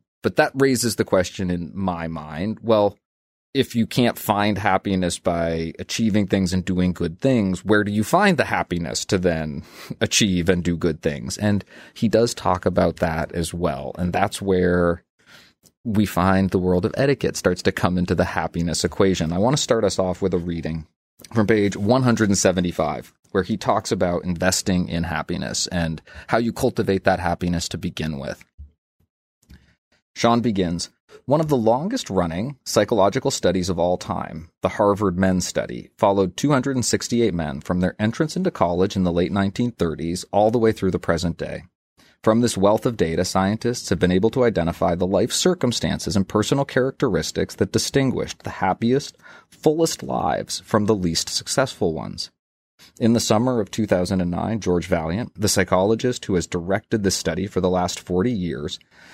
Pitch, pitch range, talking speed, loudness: 95 Hz, 85-110 Hz, 170 wpm, -21 LUFS